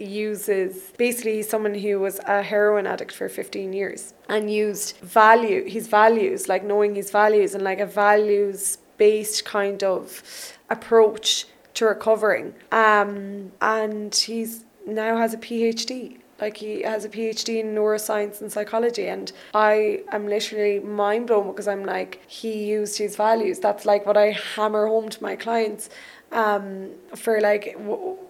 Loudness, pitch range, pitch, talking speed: -22 LUFS, 205-220 Hz, 210 Hz, 155 wpm